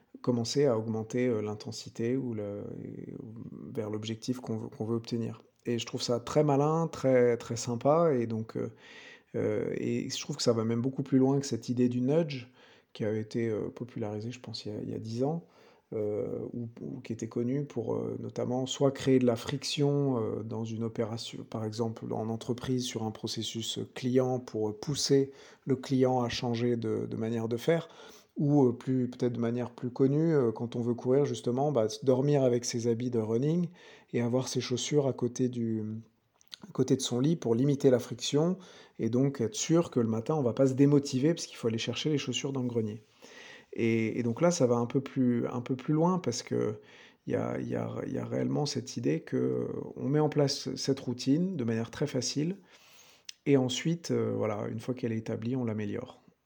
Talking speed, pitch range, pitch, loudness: 200 wpm, 115-135 Hz, 125 Hz, -31 LUFS